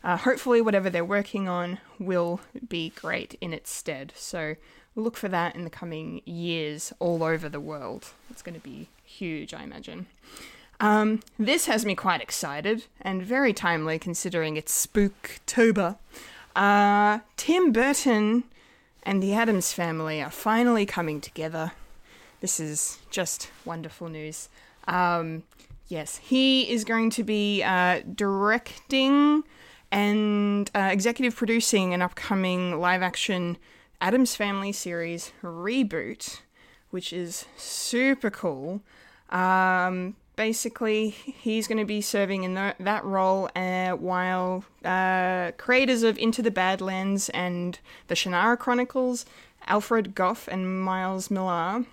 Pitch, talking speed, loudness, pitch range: 195 Hz, 130 wpm, -26 LUFS, 180-225 Hz